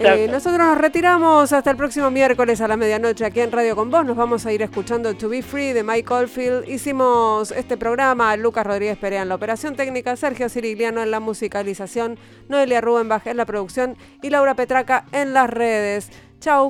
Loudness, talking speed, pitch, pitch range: -19 LUFS, 200 wpm, 235 Hz, 220-270 Hz